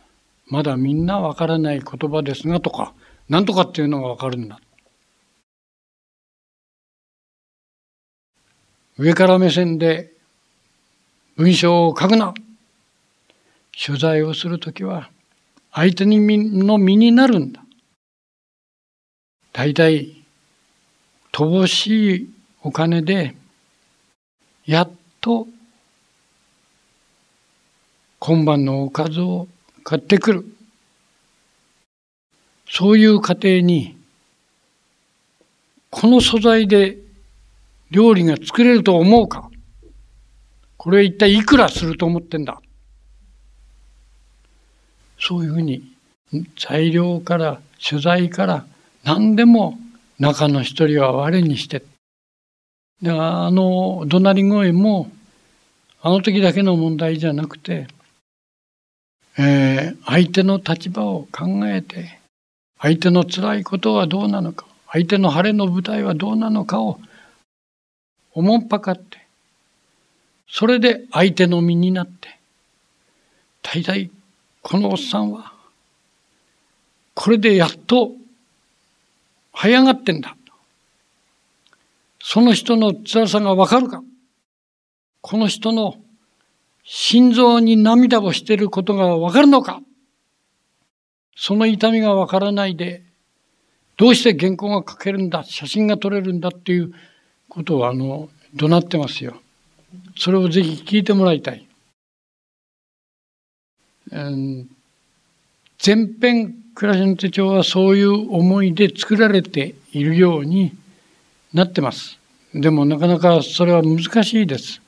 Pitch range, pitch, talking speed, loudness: 155-210 Hz, 180 Hz, 200 characters per minute, -16 LUFS